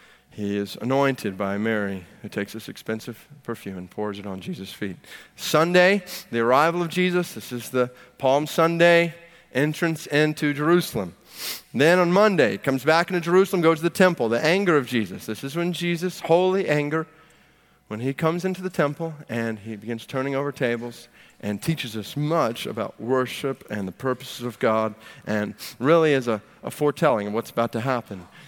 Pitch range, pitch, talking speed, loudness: 115-165 Hz, 135 Hz, 175 wpm, -23 LUFS